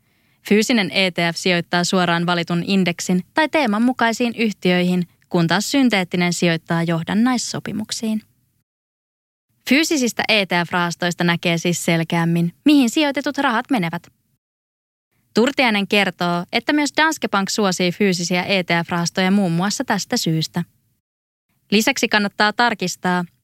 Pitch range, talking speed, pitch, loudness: 175-230 Hz, 100 wpm, 185 Hz, -18 LUFS